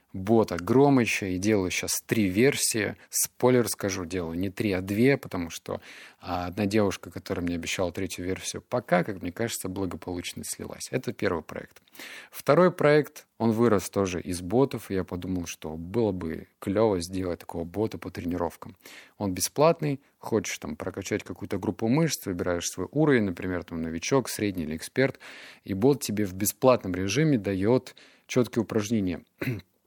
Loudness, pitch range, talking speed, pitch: -27 LUFS, 90-115 Hz, 155 wpm, 100 Hz